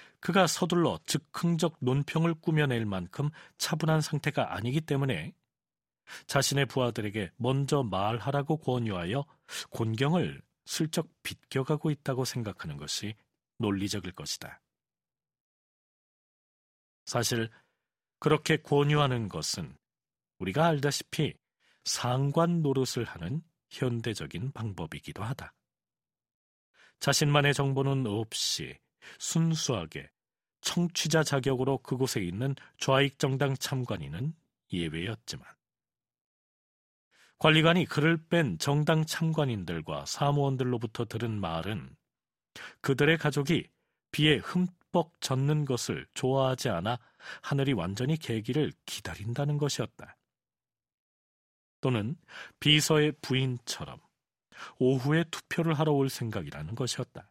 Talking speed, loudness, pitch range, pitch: 245 characters per minute, -30 LUFS, 120-155 Hz, 140 Hz